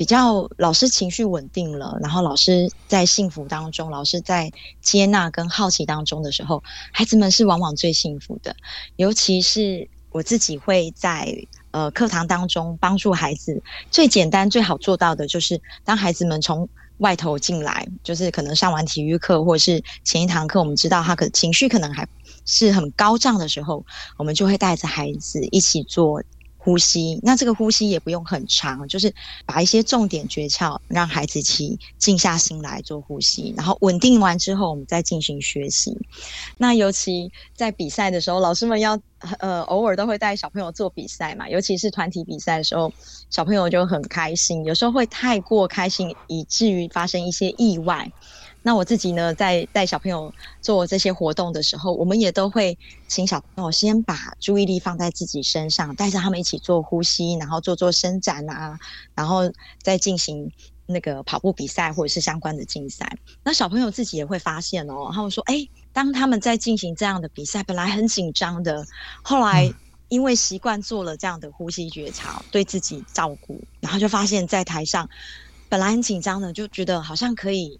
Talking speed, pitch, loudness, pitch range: 290 characters per minute, 180 Hz, -20 LUFS, 165-200 Hz